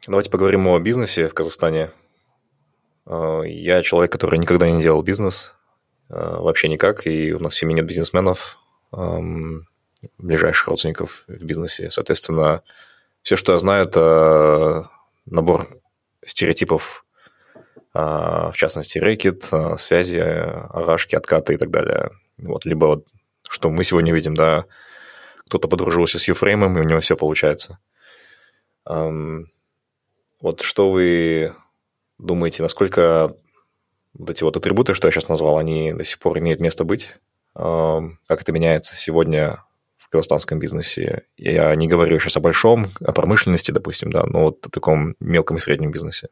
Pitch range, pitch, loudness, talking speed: 80-90 Hz, 80 Hz, -18 LUFS, 135 wpm